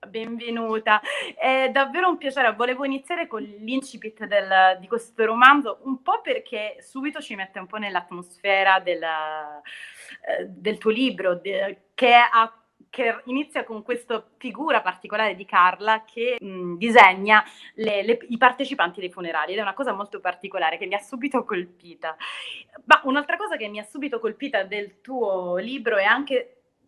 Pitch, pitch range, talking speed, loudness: 225 Hz, 195-260 Hz, 160 wpm, -22 LUFS